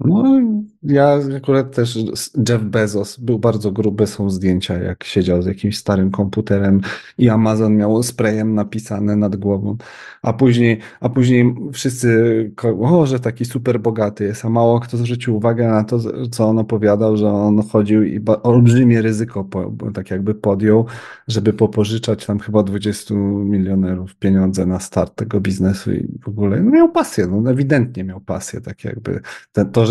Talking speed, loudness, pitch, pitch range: 165 wpm, -17 LUFS, 110 Hz, 100-120 Hz